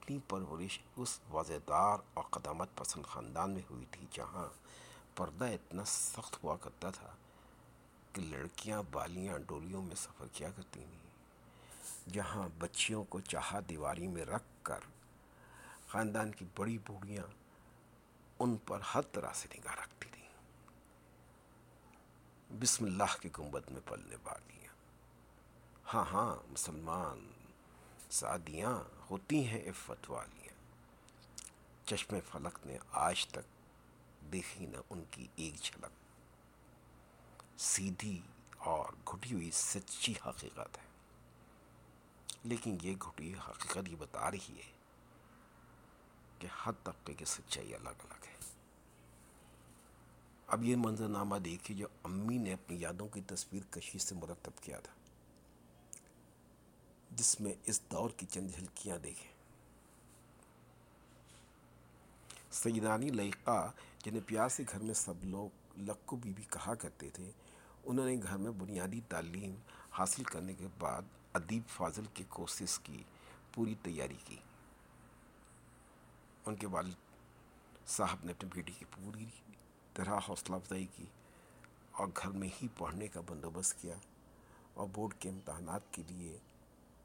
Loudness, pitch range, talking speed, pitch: -41 LUFS, 75-105 Hz, 125 wpm, 95 Hz